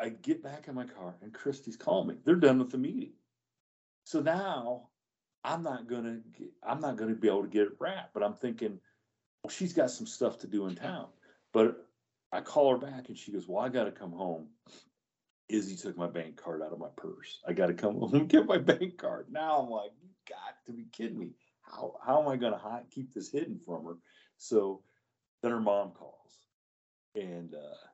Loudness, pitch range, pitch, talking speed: -33 LUFS, 95-140 Hz, 115 Hz, 215 wpm